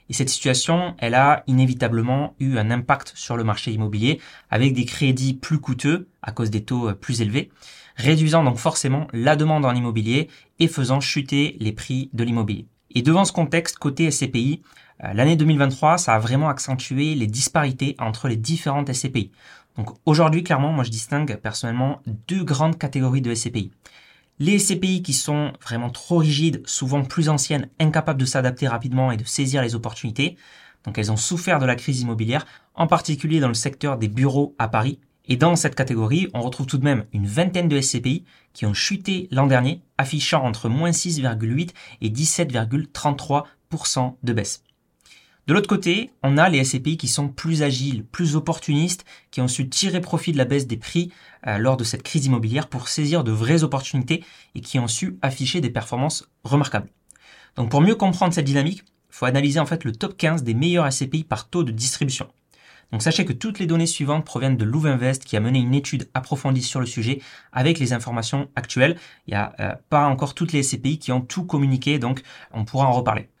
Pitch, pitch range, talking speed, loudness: 135 Hz, 125-155 Hz, 190 wpm, -21 LUFS